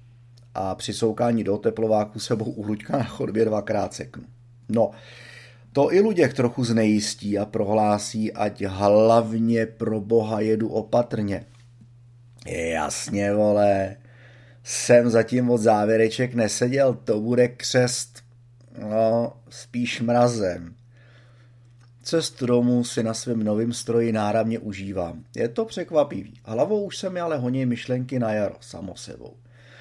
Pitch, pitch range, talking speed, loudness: 120 Hz, 110-120 Hz, 120 wpm, -23 LUFS